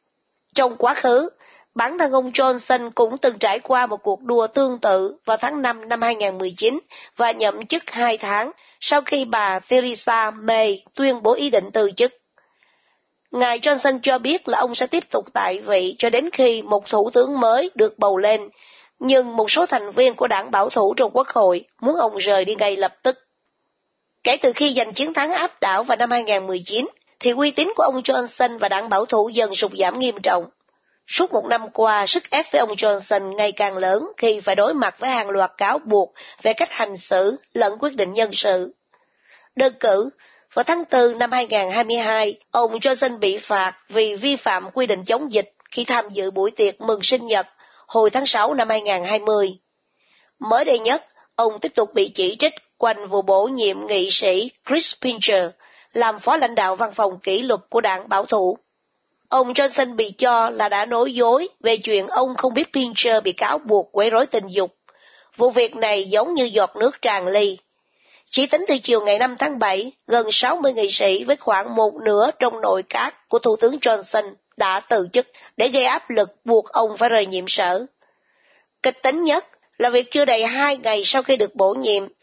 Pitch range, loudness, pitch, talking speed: 205-265 Hz, -19 LUFS, 230 Hz, 200 wpm